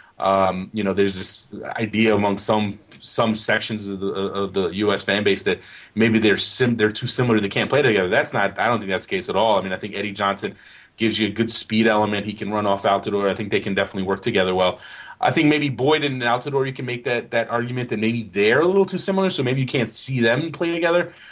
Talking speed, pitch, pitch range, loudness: 255 wpm, 110 Hz, 100-125 Hz, -21 LUFS